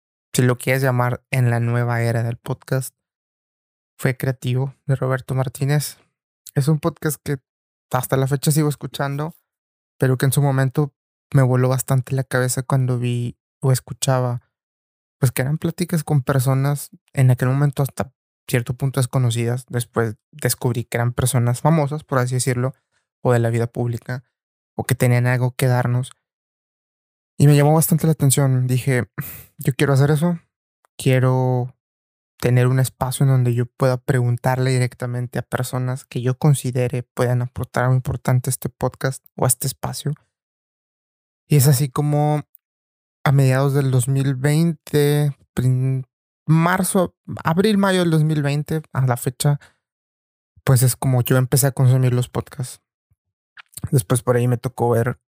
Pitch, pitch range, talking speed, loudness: 130 Hz, 125-145 Hz, 150 wpm, -20 LUFS